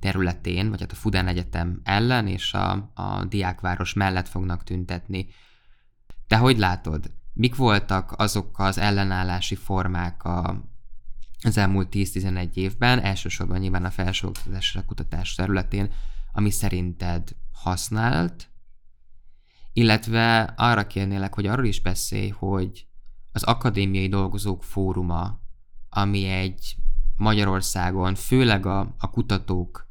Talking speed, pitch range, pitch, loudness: 110 wpm, 90-105 Hz, 95 Hz, -24 LUFS